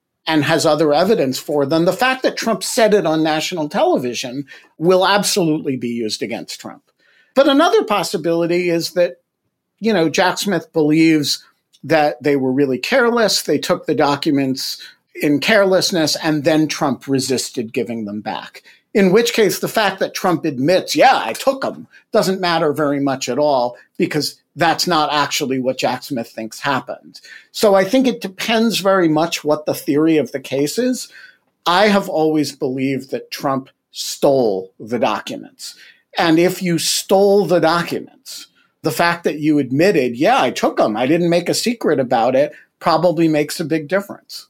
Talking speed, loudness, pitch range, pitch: 170 wpm, -17 LUFS, 145-195 Hz, 165 Hz